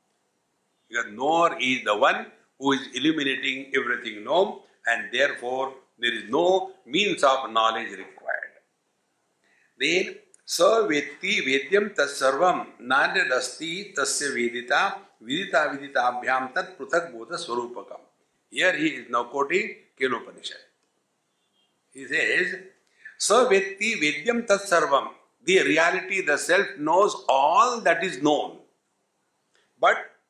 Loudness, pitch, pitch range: -24 LUFS, 145 Hz, 130-185 Hz